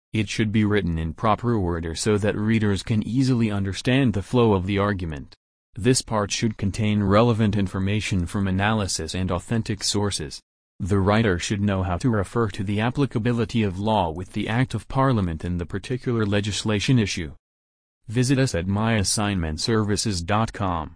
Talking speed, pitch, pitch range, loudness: 160 wpm, 105 Hz, 95-115 Hz, -23 LUFS